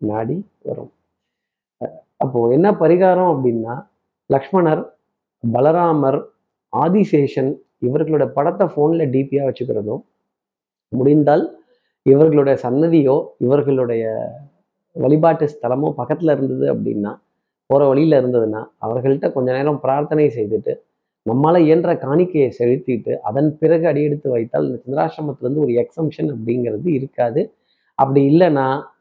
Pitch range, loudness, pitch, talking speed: 130-160 Hz, -17 LUFS, 145 Hz, 95 wpm